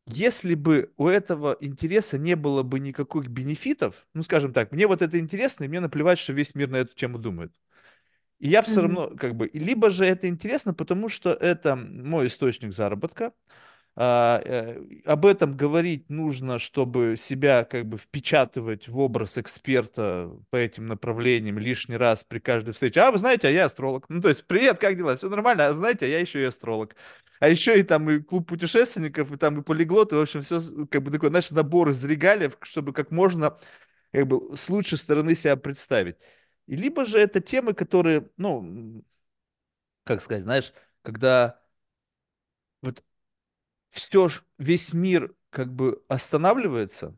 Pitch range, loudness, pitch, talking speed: 130-180 Hz, -24 LUFS, 150 Hz, 175 wpm